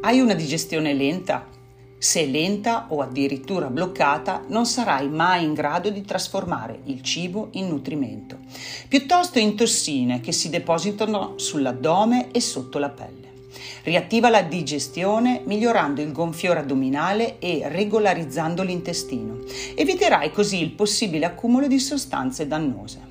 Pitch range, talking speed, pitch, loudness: 140-210 Hz, 125 wpm, 170 Hz, -22 LUFS